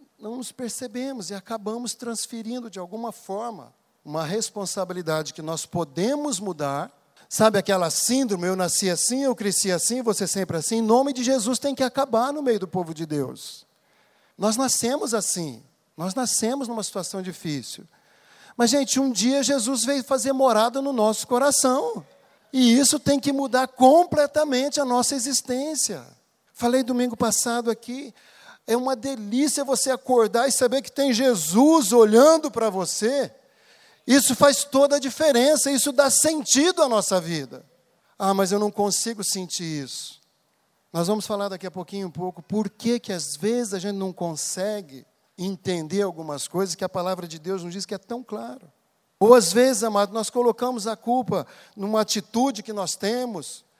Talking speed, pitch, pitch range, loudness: 165 wpm, 225 Hz, 190-260 Hz, -22 LUFS